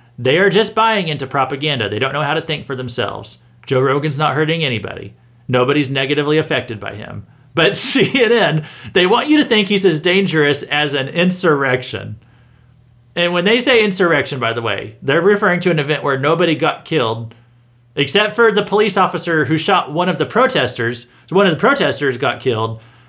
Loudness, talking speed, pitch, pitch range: -15 LUFS, 185 wpm, 150 Hz, 125-180 Hz